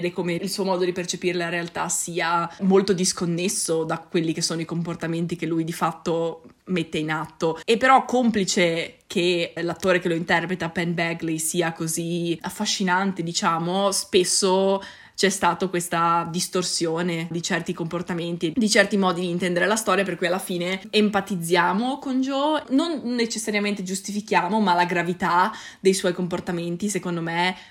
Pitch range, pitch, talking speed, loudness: 170-195 Hz, 180 Hz, 155 wpm, -23 LUFS